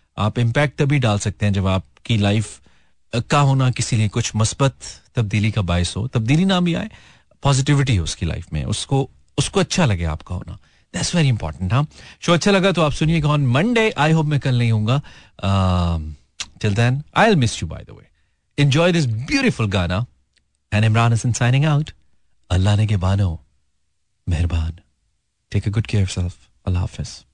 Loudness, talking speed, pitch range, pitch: -19 LUFS, 180 wpm, 90-140 Hz, 110 Hz